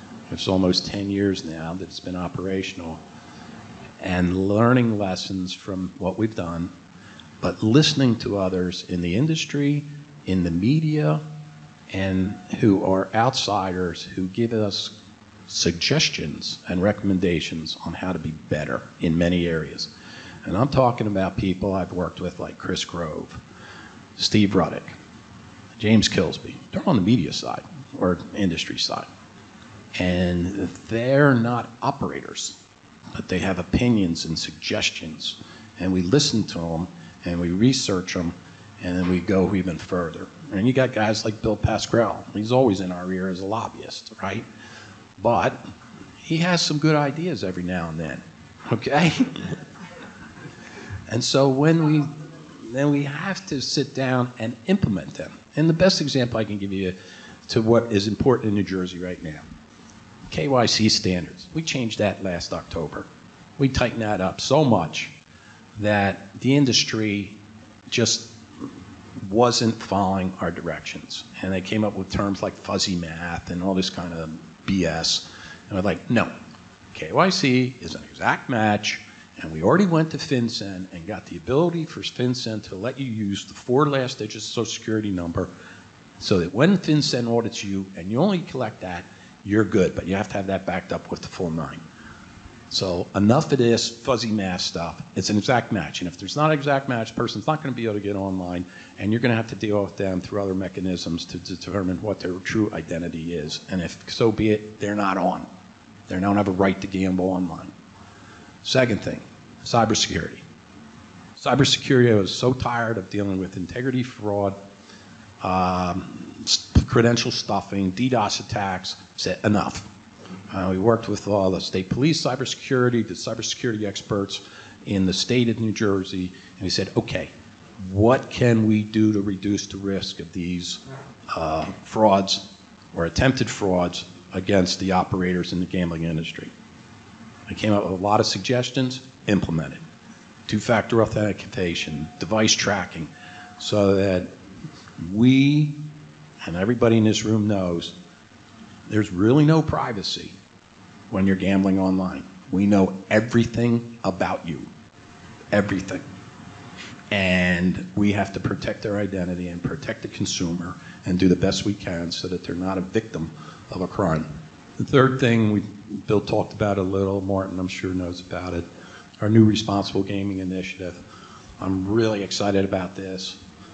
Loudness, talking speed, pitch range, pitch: -22 LUFS, 160 wpm, 90-115 Hz, 100 Hz